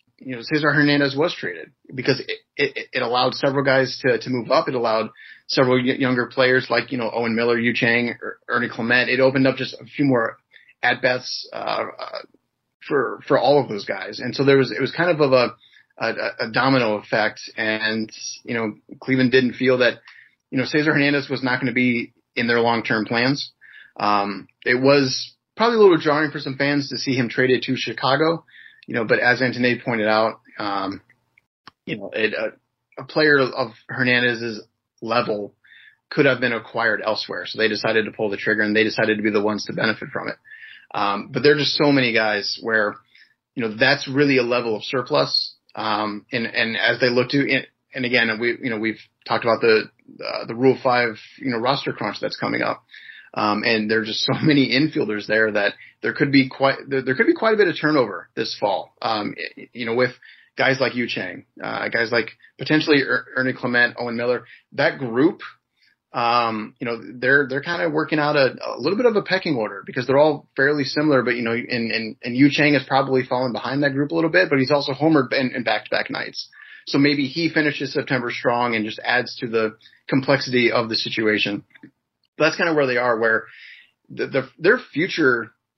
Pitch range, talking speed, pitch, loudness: 115-140 Hz, 210 wpm, 125 Hz, -20 LUFS